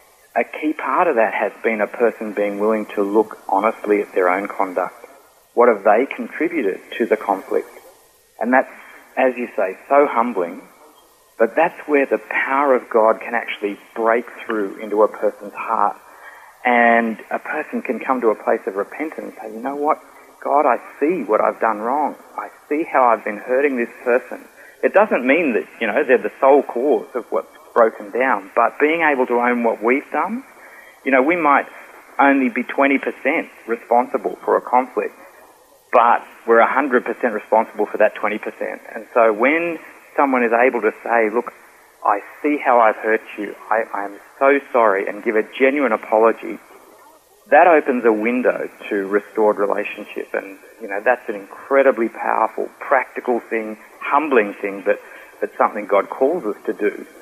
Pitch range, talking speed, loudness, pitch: 110-165 Hz, 175 wpm, -18 LUFS, 130 Hz